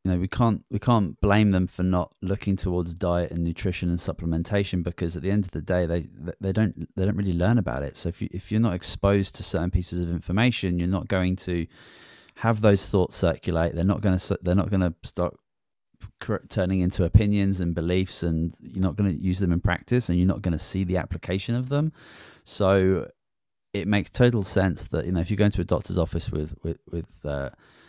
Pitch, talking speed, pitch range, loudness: 95 Hz, 225 wpm, 85-100 Hz, -25 LUFS